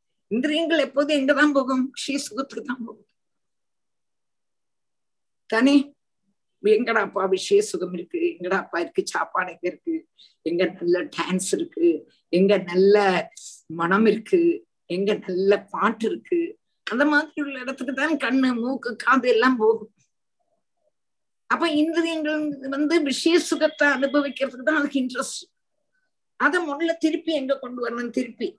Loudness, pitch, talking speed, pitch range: -23 LUFS, 275 Hz, 115 wpm, 220-325 Hz